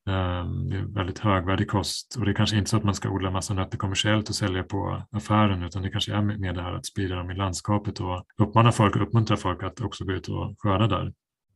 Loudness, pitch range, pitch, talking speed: -26 LUFS, 95-105 Hz, 100 Hz, 245 wpm